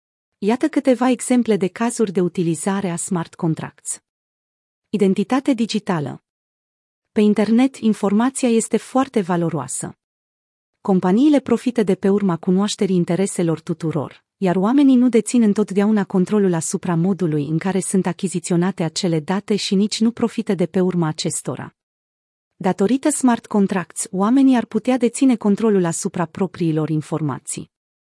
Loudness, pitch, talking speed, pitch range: -19 LUFS, 195 Hz, 125 wpm, 170-225 Hz